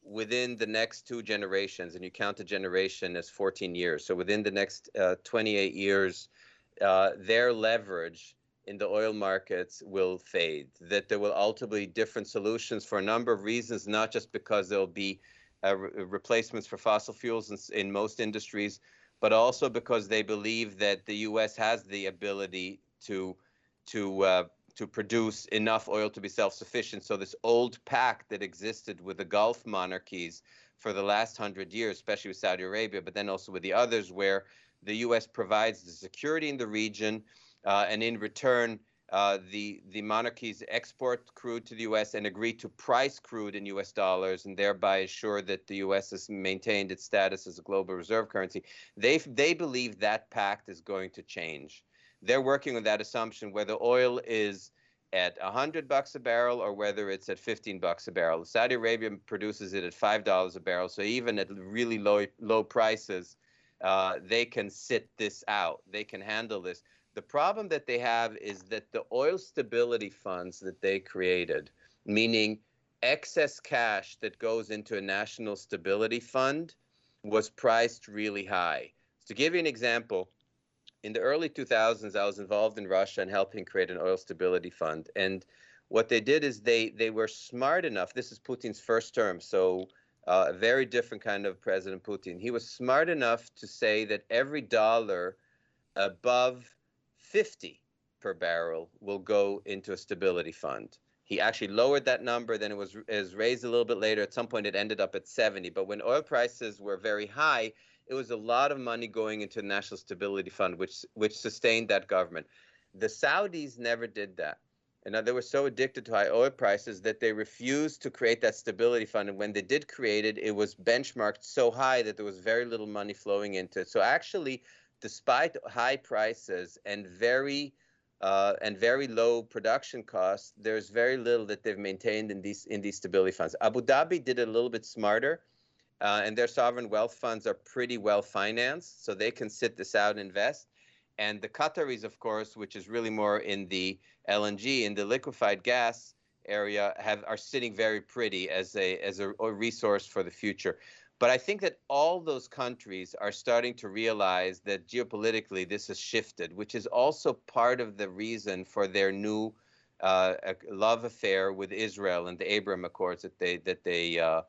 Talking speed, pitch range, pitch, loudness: 185 wpm, 100-120 Hz, 105 Hz, -31 LUFS